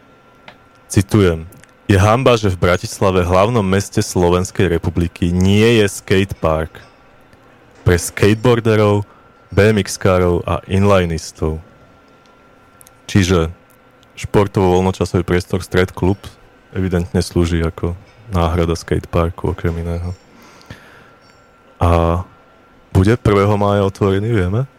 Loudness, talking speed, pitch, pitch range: -16 LUFS, 90 wpm, 95 Hz, 85-105 Hz